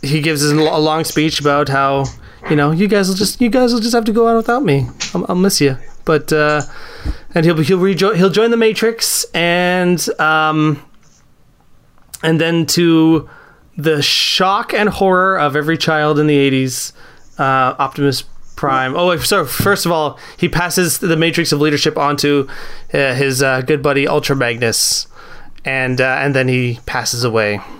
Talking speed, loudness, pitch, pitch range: 180 wpm, -14 LUFS, 155 Hz, 140-180 Hz